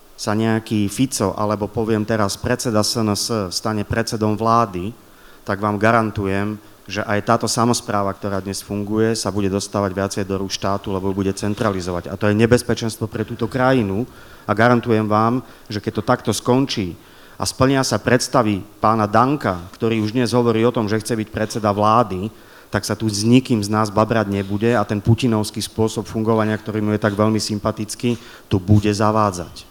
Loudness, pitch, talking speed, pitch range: -19 LUFS, 110 Hz, 175 wpm, 105-115 Hz